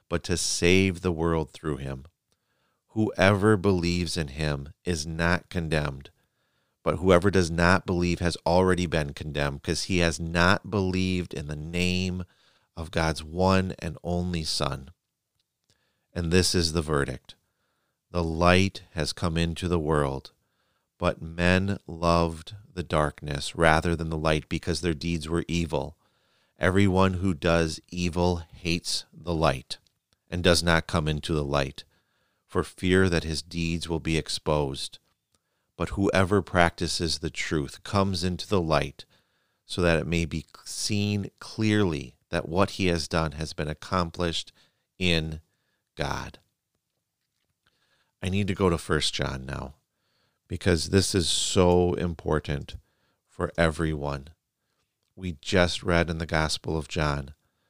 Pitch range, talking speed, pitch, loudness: 80-90 Hz, 140 wpm, 85 Hz, -26 LUFS